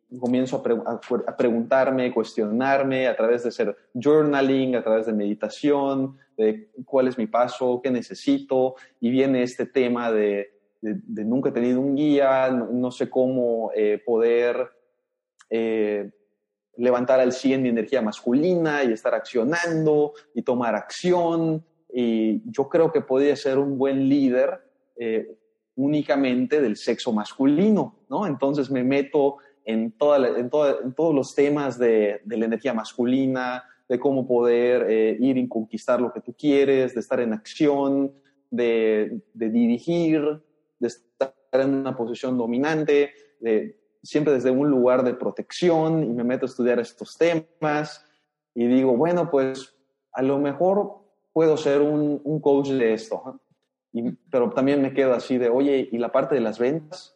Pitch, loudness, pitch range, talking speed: 130 Hz, -23 LUFS, 120-145 Hz, 165 wpm